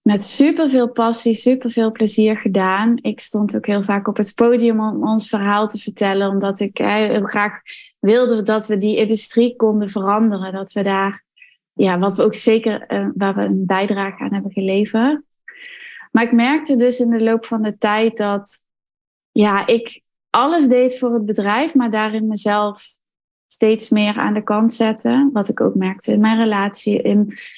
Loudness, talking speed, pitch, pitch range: -17 LUFS, 180 wpm, 220 Hz, 205-235 Hz